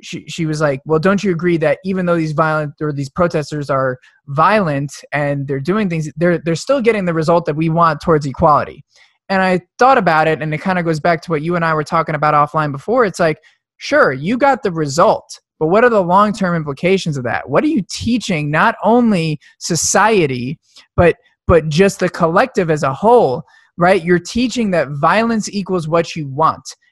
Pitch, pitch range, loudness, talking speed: 170 Hz, 155-195 Hz, -15 LUFS, 205 wpm